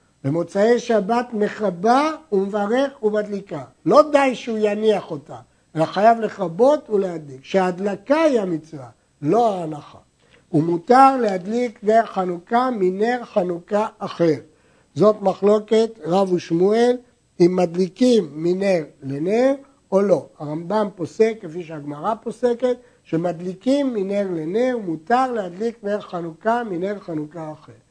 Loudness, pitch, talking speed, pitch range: -20 LUFS, 200 Hz, 110 wpm, 170-230 Hz